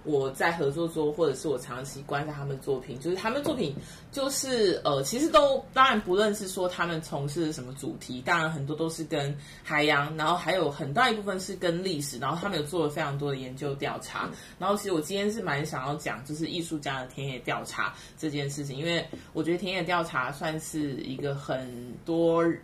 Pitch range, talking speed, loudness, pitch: 140-180 Hz, 325 characters per minute, -29 LUFS, 155 Hz